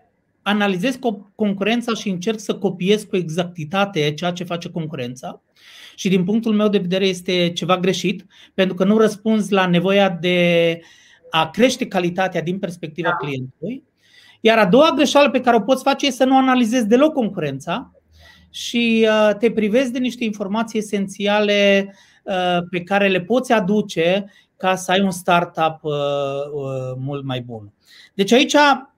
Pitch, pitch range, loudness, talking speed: 195 Hz, 175-225 Hz, -18 LUFS, 145 wpm